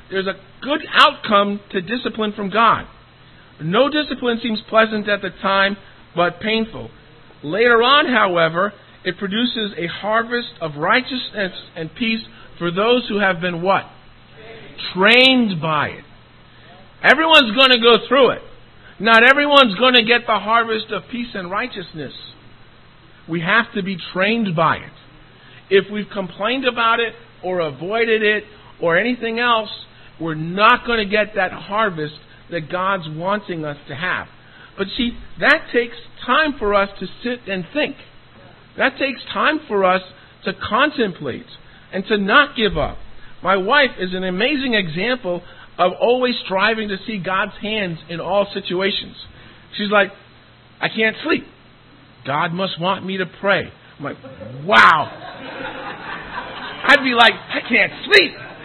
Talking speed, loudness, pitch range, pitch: 145 wpm, -17 LUFS, 175-235 Hz, 200 Hz